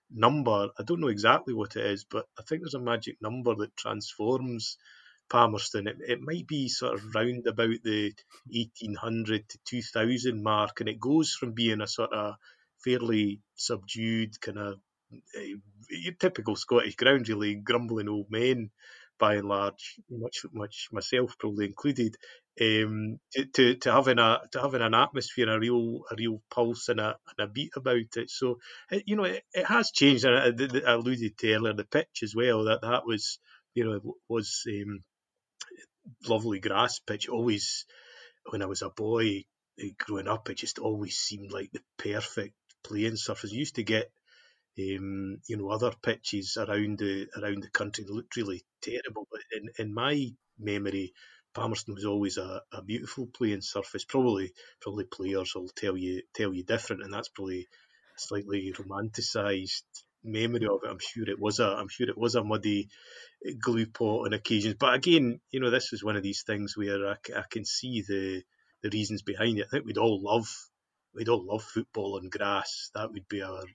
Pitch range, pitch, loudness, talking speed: 105-120 Hz, 110 Hz, -30 LUFS, 180 wpm